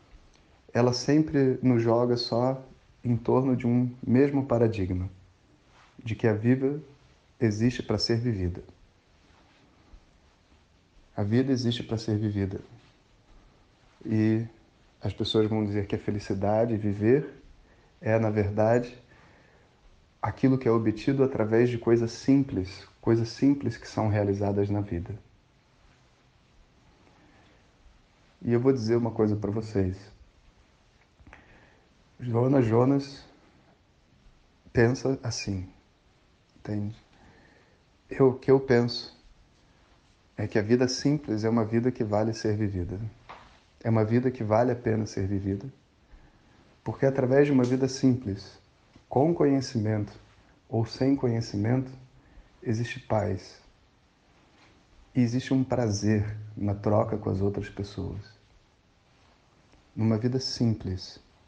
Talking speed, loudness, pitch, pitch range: 115 wpm, -27 LUFS, 110 Hz, 100-125 Hz